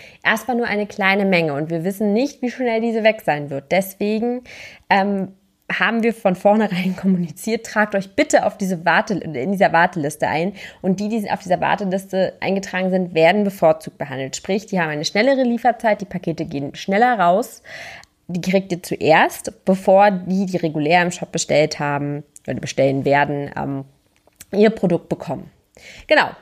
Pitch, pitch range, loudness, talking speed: 190 Hz, 165-210 Hz, -19 LUFS, 170 wpm